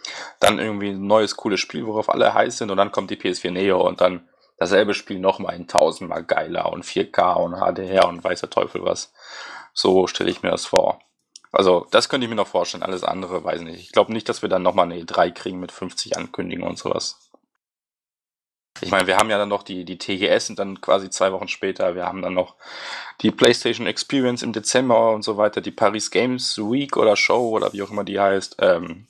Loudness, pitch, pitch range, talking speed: -21 LUFS, 100 Hz, 95-110 Hz, 220 wpm